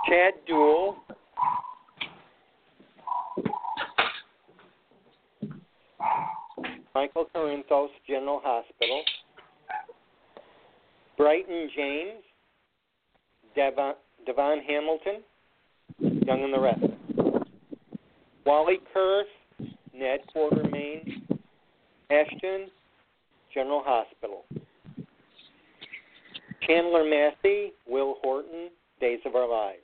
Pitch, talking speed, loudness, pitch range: 160 Hz, 60 wpm, -27 LUFS, 145-205 Hz